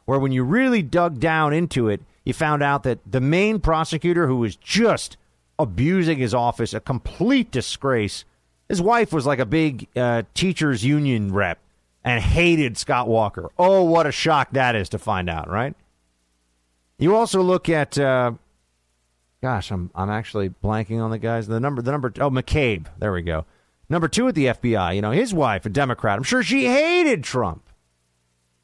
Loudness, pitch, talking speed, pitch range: -21 LUFS, 125 Hz, 180 wpm, 95-155 Hz